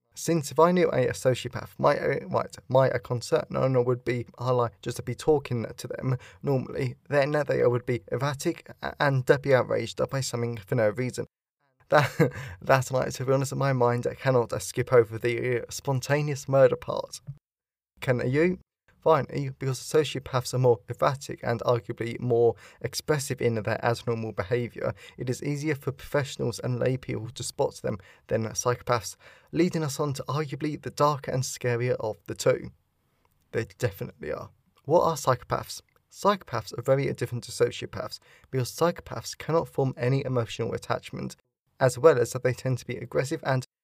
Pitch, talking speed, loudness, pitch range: 125 Hz, 180 wpm, -27 LUFS, 120-140 Hz